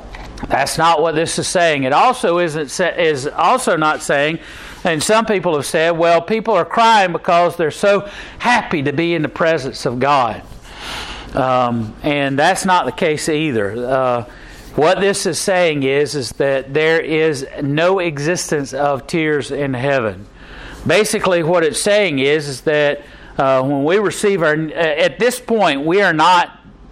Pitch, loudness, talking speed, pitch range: 160 Hz, -16 LUFS, 165 wpm, 140-185 Hz